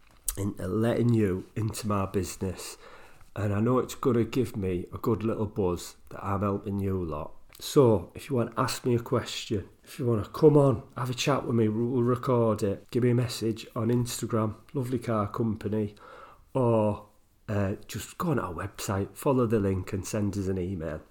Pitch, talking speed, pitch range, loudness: 110 Hz, 200 wpm, 100-120 Hz, -28 LUFS